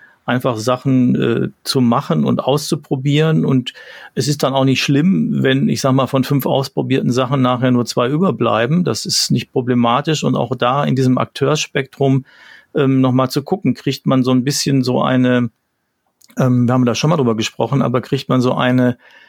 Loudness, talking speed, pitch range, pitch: -16 LUFS, 190 wpm, 125-140 Hz, 130 Hz